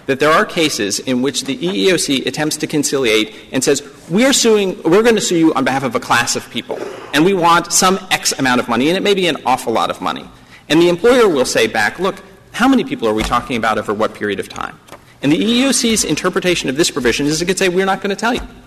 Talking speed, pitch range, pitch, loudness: 260 wpm, 135-195 Hz, 170 Hz, -15 LUFS